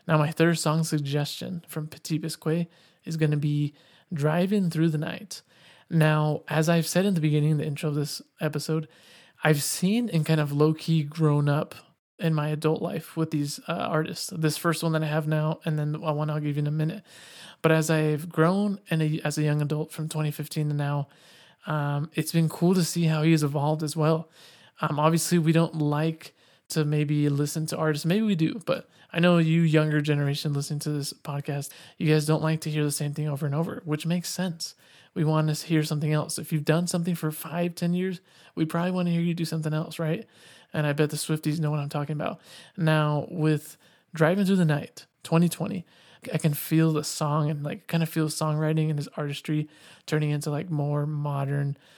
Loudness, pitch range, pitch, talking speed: -26 LUFS, 150-165 Hz, 155 Hz, 215 wpm